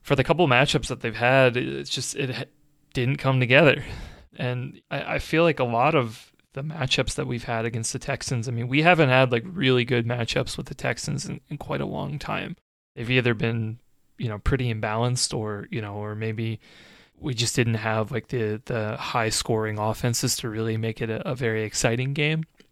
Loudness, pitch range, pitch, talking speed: -24 LUFS, 115-135 Hz, 125 Hz, 210 wpm